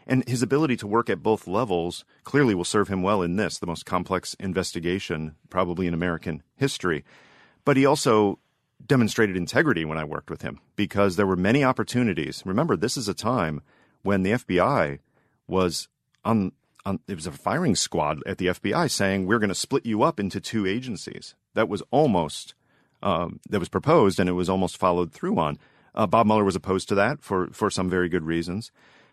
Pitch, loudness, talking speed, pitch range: 100 Hz, -24 LUFS, 190 wpm, 90-115 Hz